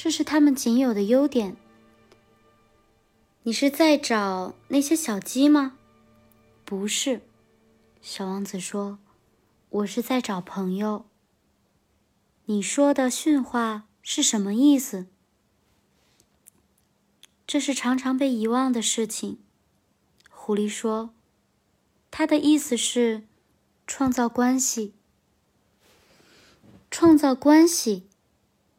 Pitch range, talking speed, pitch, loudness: 205-275 Hz, 140 characters per minute, 235 Hz, -23 LUFS